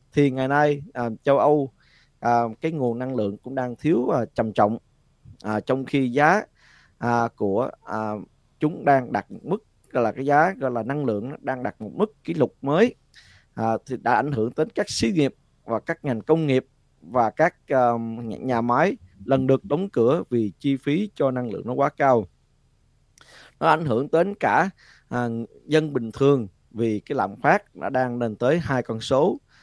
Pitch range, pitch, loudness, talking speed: 115-140 Hz, 130 Hz, -23 LUFS, 195 wpm